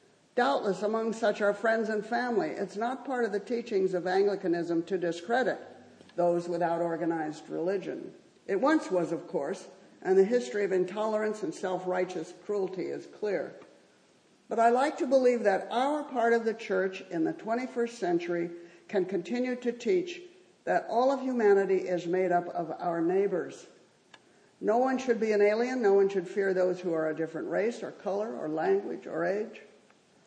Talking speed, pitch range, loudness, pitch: 175 wpm, 180-235 Hz, -30 LUFS, 200 Hz